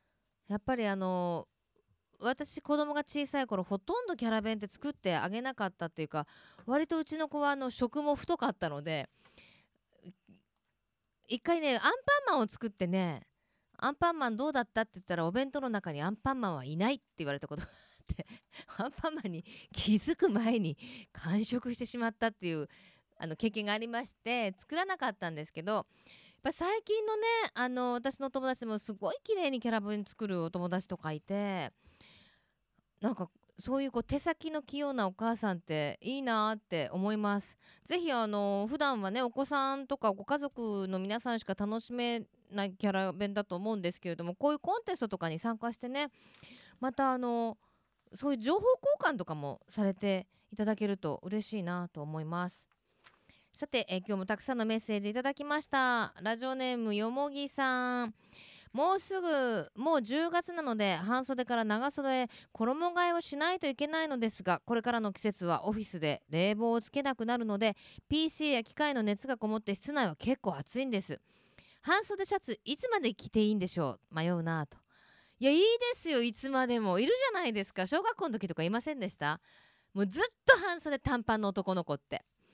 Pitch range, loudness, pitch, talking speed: 195-280 Hz, -34 LUFS, 230 Hz, 370 characters per minute